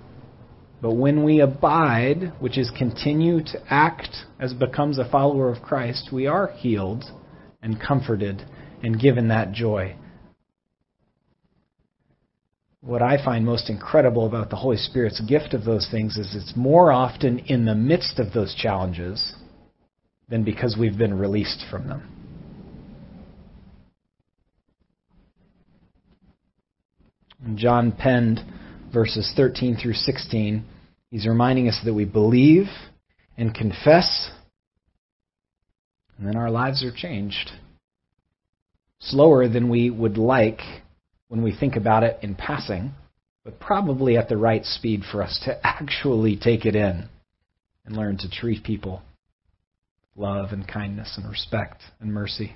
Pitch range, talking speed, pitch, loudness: 100-125 Hz, 130 wpm, 115 Hz, -22 LUFS